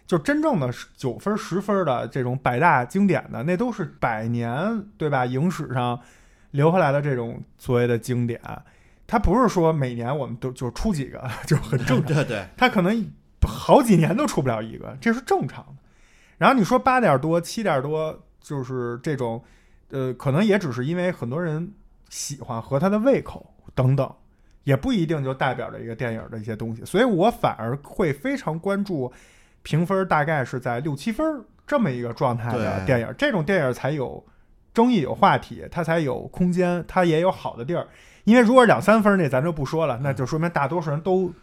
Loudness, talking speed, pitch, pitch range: -23 LUFS, 285 characters per minute, 150 Hz, 125-190 Hz